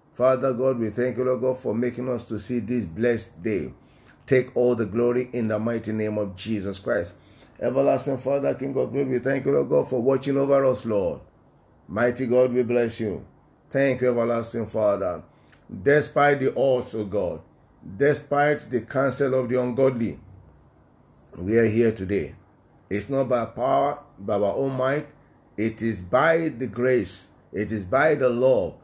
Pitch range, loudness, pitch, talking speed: 115-135 Hz, -24 LUFS, 125 Hz, 170 wpm